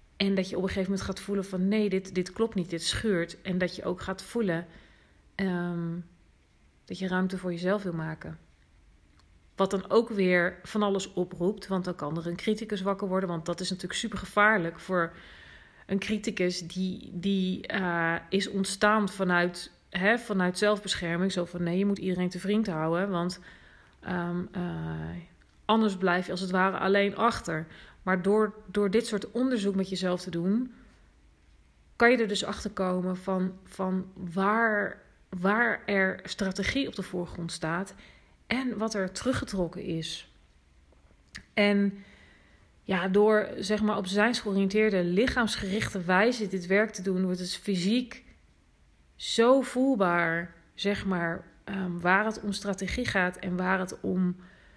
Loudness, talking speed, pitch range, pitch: -29 LUFS, 160 wpm, 175-205 Hz, 190 Hz